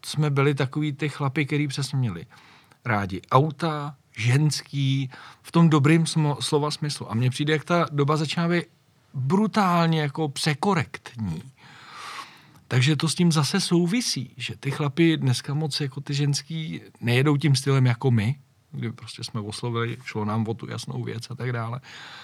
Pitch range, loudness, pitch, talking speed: 125-155 Hz, -24 LUFS, 145 Hz, 160 wpm